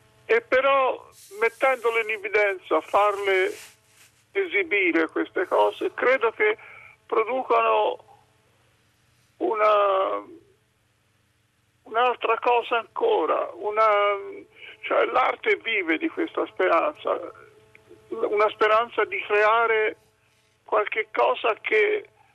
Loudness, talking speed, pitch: -23 LUFS, 80 wpm, 230 Hz